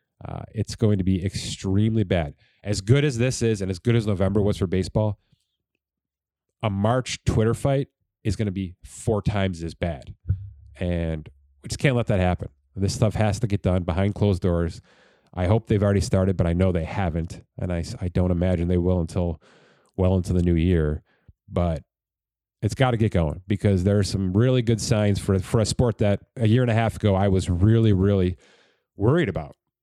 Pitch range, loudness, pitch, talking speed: 90-110 Hz, -23 LUFS, 100 Hz, 205 wpm